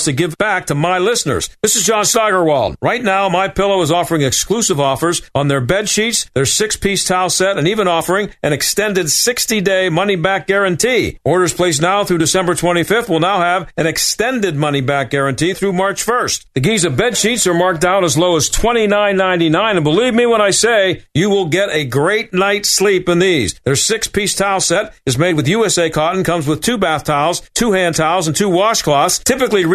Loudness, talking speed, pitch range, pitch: -14 LUFS, 195 wpm, 165-205 Hz, 185 Hz